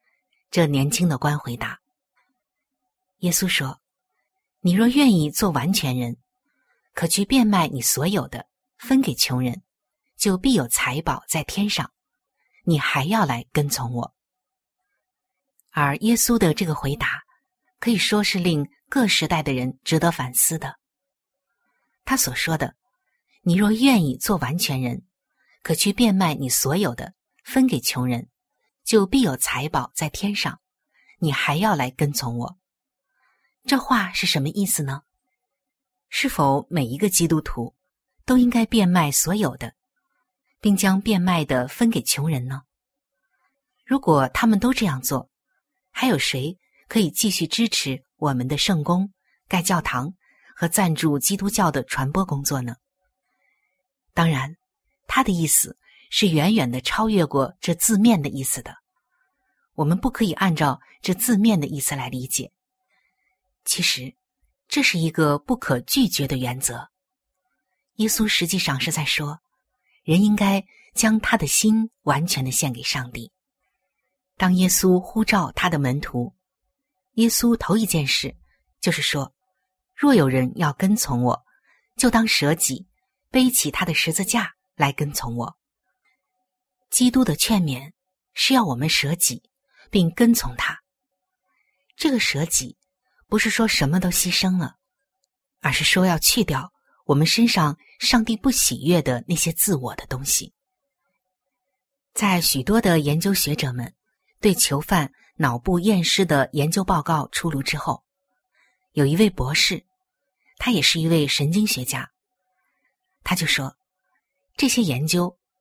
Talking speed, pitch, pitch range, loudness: 200 characters per minute, 185 Hz, 145-230 Hz, -21 LUFS